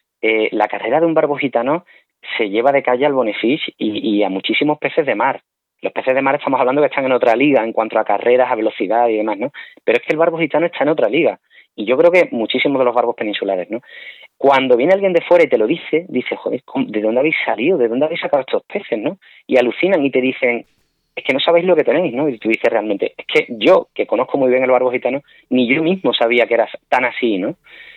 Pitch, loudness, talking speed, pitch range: 140 Hz, -16 LUFS, 255 wpm, 120-170 Hz